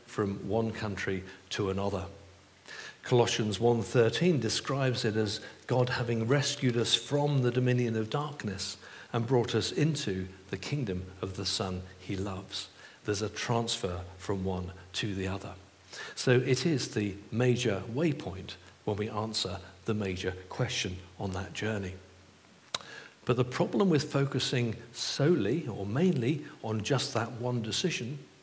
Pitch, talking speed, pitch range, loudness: 110 Hz, 140 wpm, 95-125 Hz, -31 LUFS